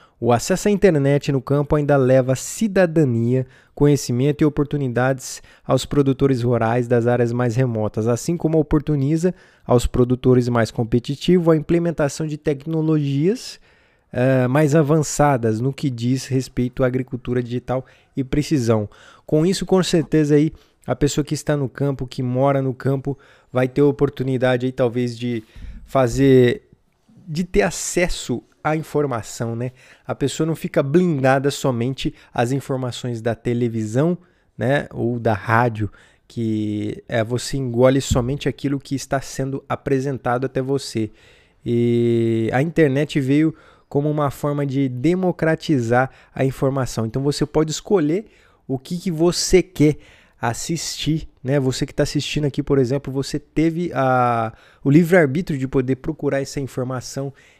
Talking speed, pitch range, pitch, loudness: 145 wpm, 125-150 Hz, 135 Hz, -20 LUFS